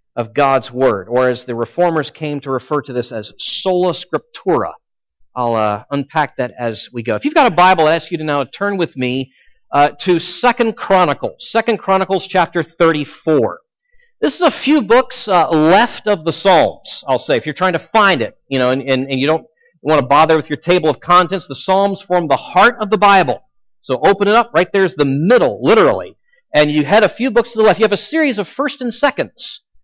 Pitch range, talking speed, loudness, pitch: 140-210 Hz, 220 wpm, -15 LUFS, 170 Hz